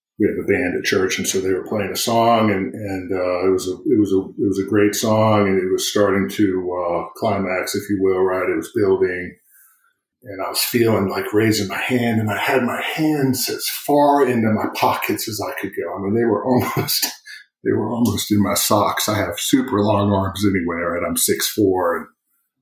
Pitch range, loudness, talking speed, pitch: 95-115 Hz, -19 LUFS, 225 wpm, 100 Hz